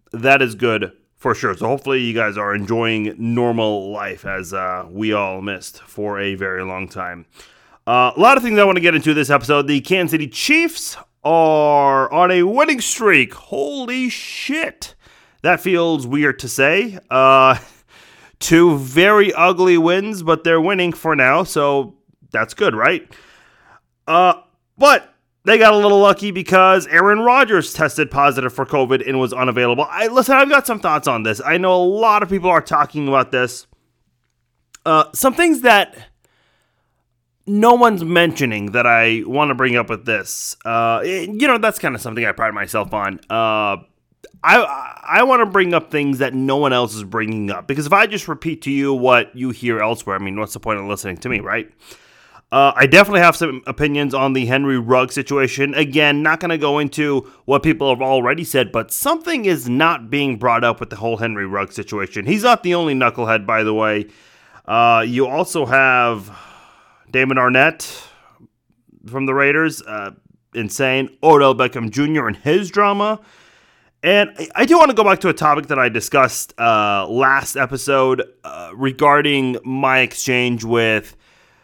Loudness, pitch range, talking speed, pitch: -15 LUFS, 115-170 Hz, 180 wpm, 135 Hz